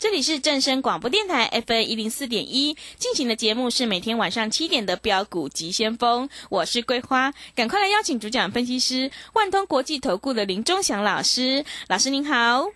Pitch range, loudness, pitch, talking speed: 225-290 Hz, -22 LUFS, 255 Hz, 300 characters per minute